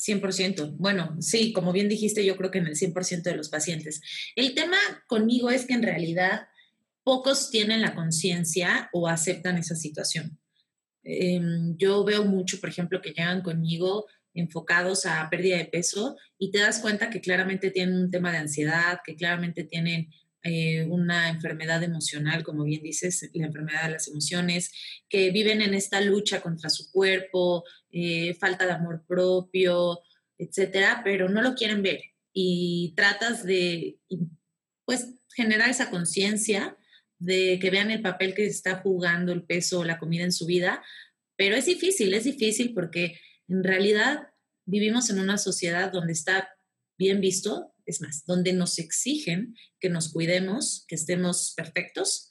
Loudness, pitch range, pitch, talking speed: -26 LUFS, 170-200 Hz, 185 Hz, 160 wpm